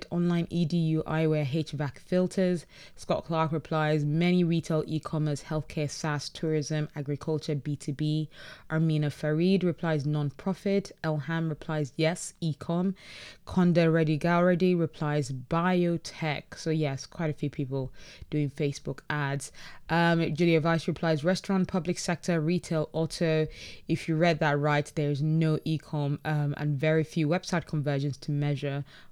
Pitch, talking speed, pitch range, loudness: 155 Hz, 130 wpm, 150-170 Hz, -29 LUFS